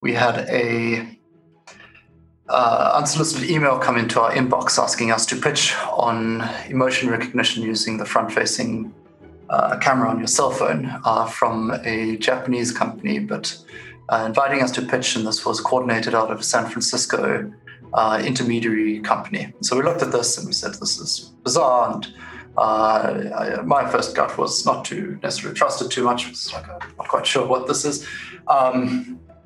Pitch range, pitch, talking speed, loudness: 110-125 Hz, 115 Hz, 170 wpm, -20 LUFS